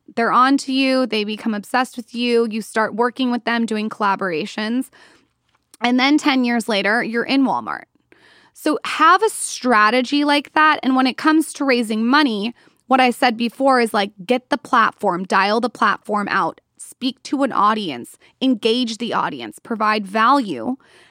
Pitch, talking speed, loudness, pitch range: 245 Hz, 170 wpm, -18 LUFS, 220-265 Hz